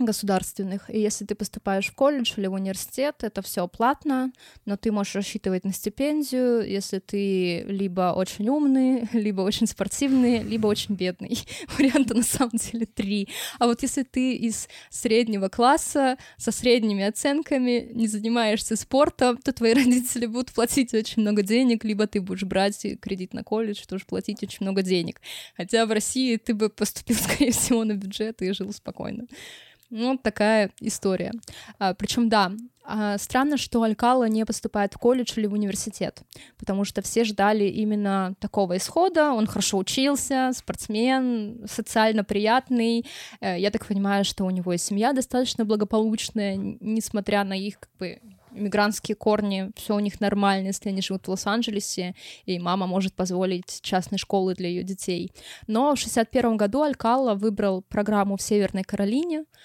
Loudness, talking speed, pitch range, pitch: -24 LUFS, 155 wpm, 195-240 Hz, 215 Hz